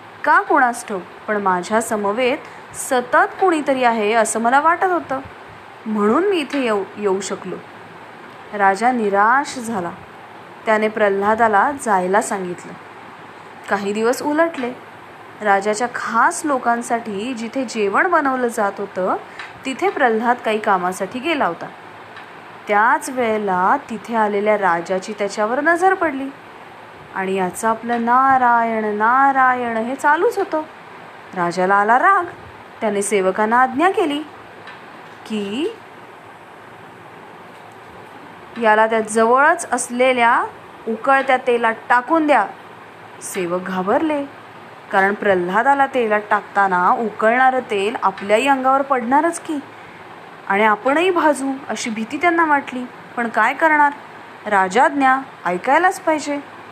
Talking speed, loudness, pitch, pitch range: 105 wpm, -17 LUFS, 235 Hz, 210-275 Hz